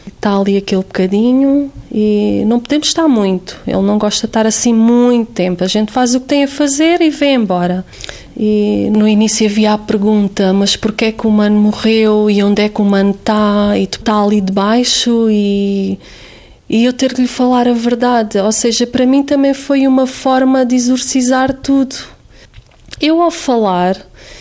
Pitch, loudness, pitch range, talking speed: 225 Hz, -12 LUFS, 205-255 Hz, 185 wpm